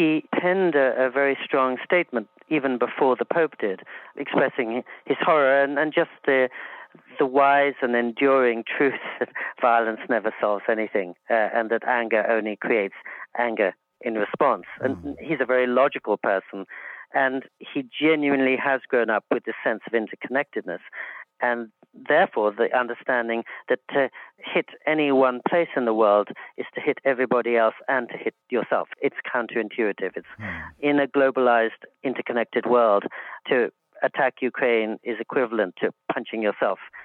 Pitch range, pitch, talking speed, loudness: 115-140 Hz, 125 Hz, 150 wpm, -23 LUFS